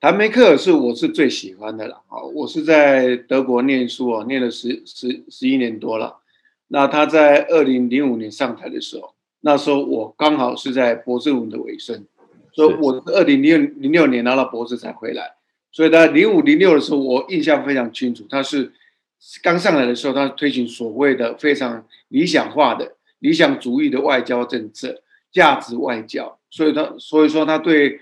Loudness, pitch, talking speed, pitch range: -17 LUFS, 140 Hz, 280 characters per minute, 125-165 Hz